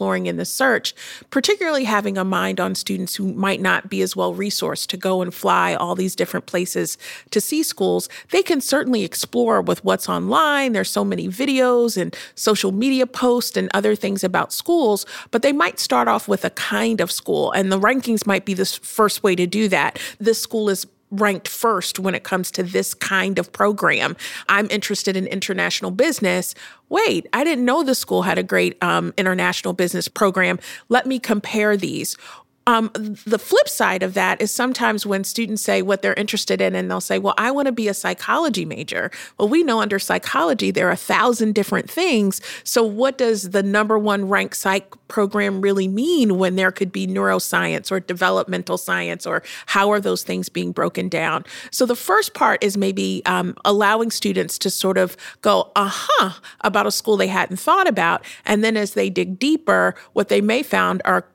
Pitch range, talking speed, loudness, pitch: 185-230 Hz, 195 wpm, -19 LUFS, 200 Hz